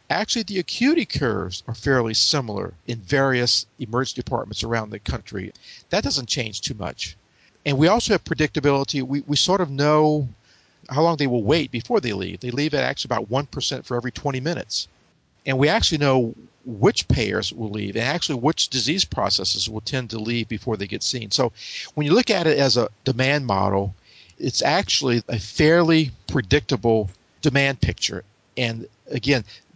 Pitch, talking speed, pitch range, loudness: 130 Hz, 175 wpm, 110-145 Hz, -22 LUFS